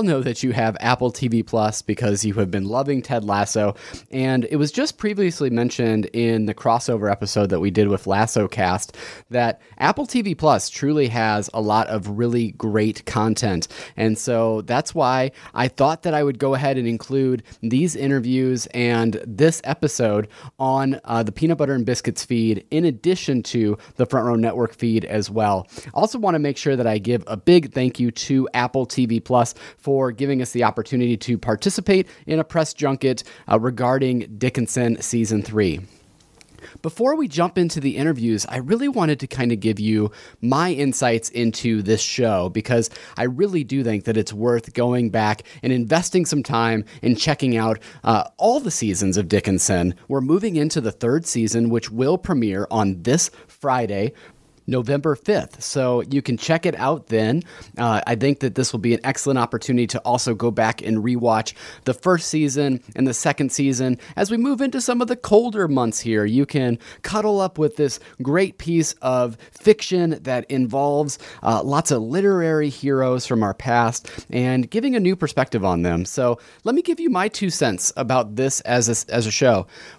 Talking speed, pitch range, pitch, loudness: 185 wpm, 115-145 Hz, 125 Hz, -21 LUFS